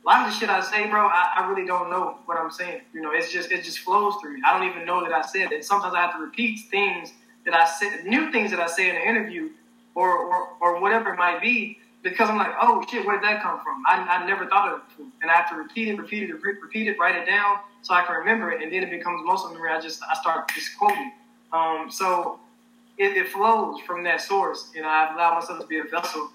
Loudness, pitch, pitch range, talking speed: -23 LUFS, 200 Hz, 175-230 Hz, 280 wpm